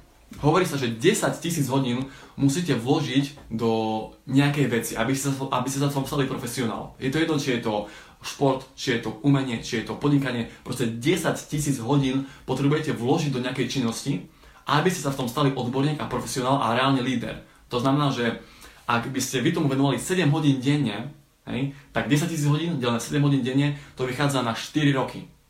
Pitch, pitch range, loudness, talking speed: 135 Hz, 125-145 Hz, -25 LUFS, 185 wpm